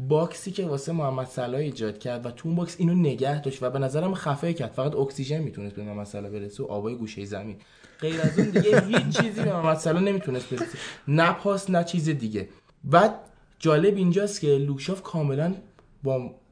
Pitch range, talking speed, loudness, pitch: 125-170 Hz, 195 wpm, -26 LUFS, 145 Hz